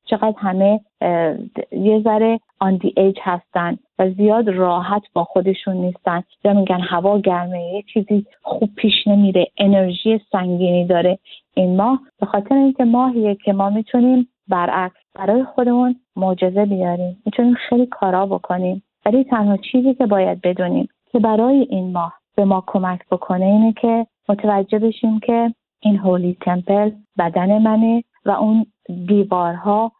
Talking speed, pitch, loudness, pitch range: 140 wpm, 205 Hz, -17 LUFS, 185-225 Hz